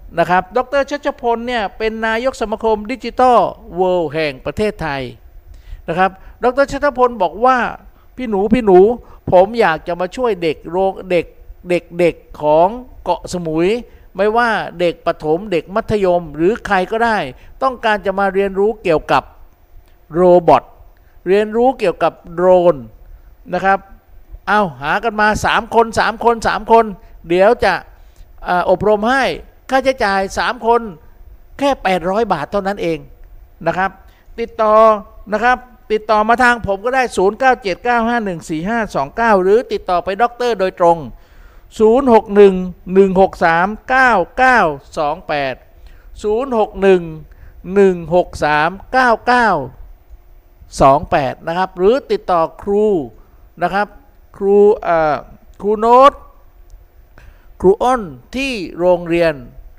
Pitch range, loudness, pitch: 170-230 Hz, -15 LUFS, 195 Hz